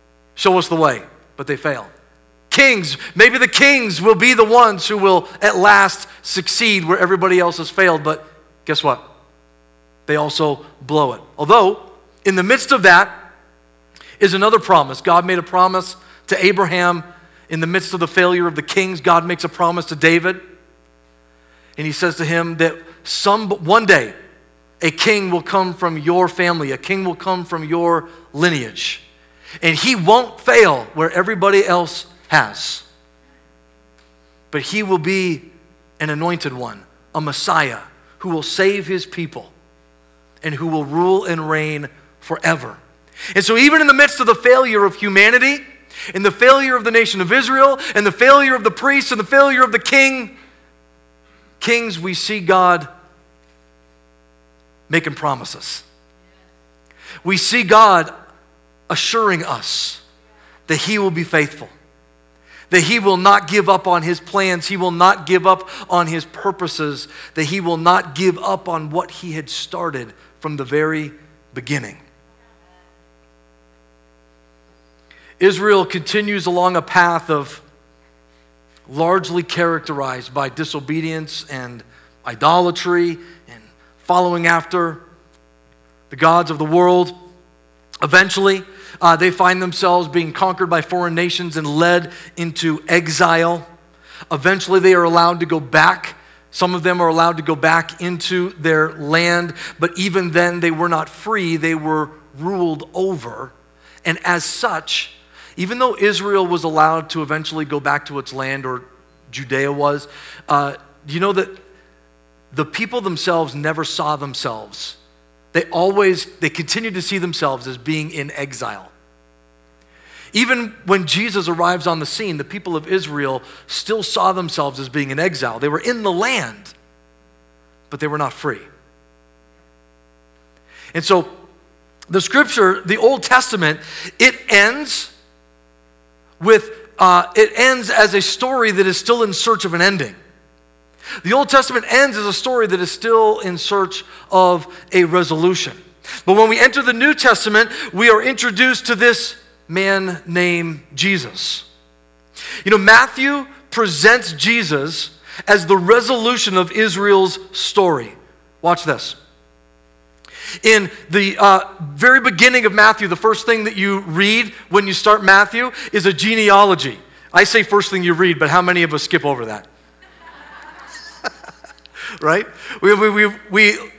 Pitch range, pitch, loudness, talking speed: 135-195 Hz, 170 Hz, -15 LUFS, 150 wpm